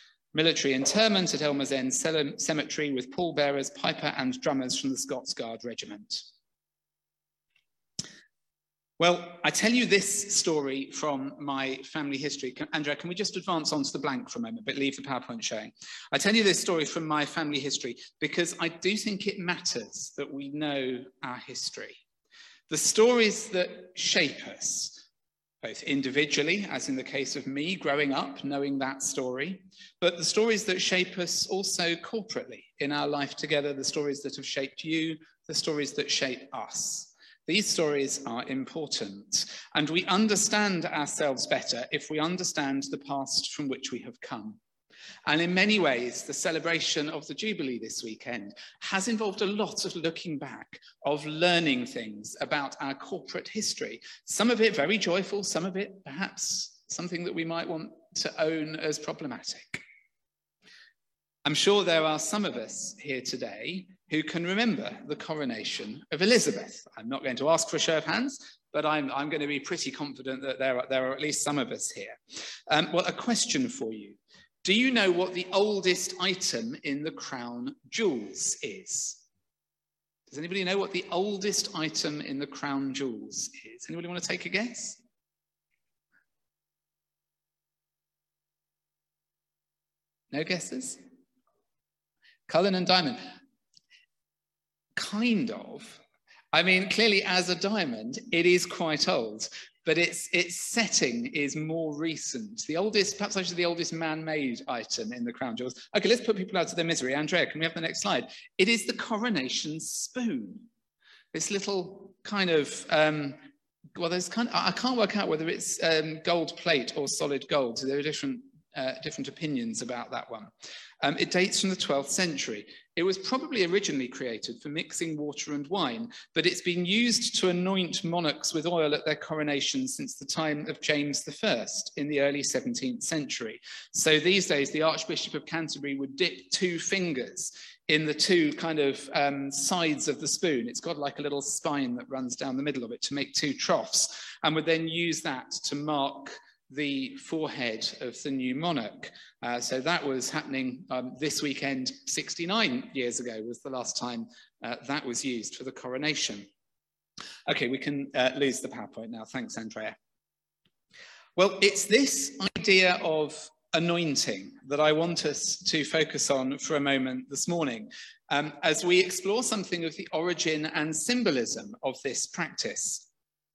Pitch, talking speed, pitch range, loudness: 160 Hz, 170 wpm, 140-195 Hz, -29 LUFS